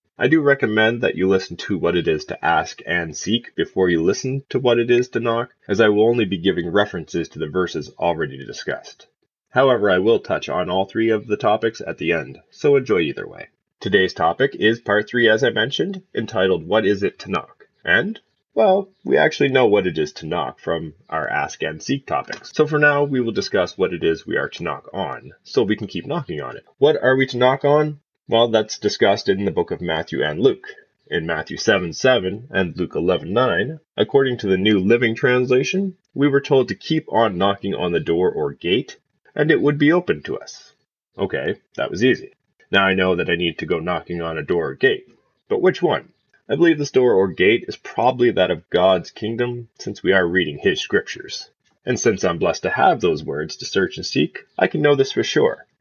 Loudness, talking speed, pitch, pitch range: -19 LUFS, 225 wpm, 120 Hz, 100-150 Hz